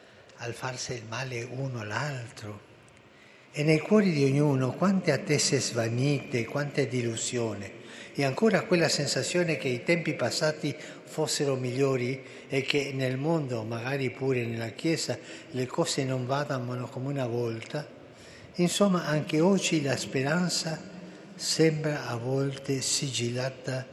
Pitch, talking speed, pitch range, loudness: 135 Hz, 125 wpm, 125-155 Hz, -28 LUFS